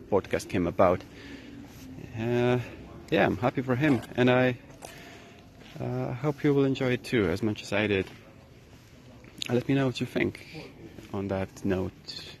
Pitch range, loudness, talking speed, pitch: 110-135 Hz, -28 LUFS, 155 wpm, 125 Hz